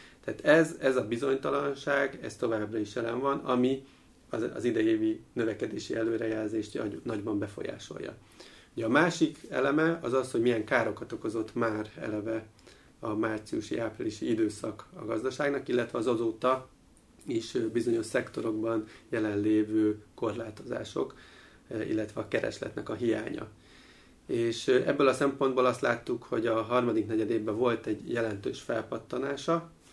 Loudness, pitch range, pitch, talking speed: -31 LUFS, 110-140 Hz, 125 Hz, 125 wpm